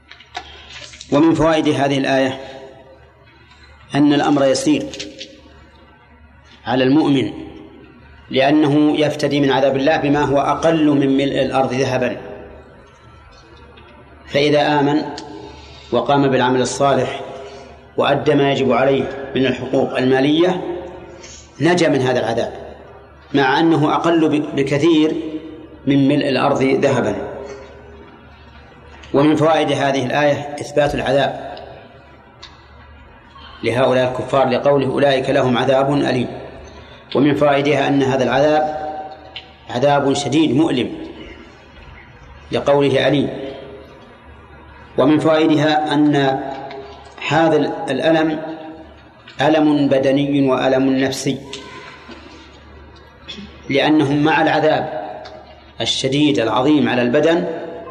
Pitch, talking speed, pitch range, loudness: 140 Hz, 85 wpm, 130-150 Hz, -16 LUFS